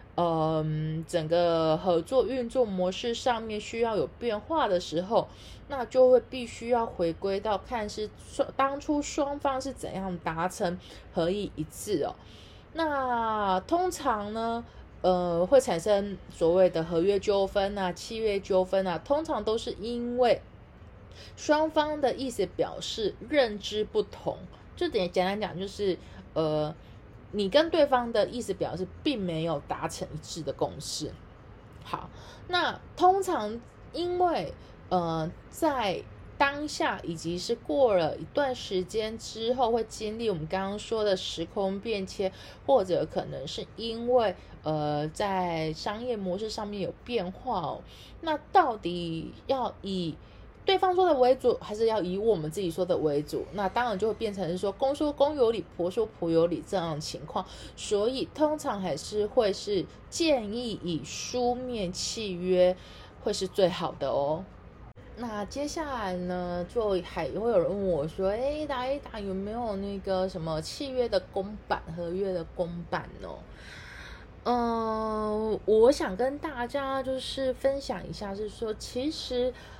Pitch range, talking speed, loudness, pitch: 180-255 Hz, 215 characters per minute, -29 LUFS, 210 Hz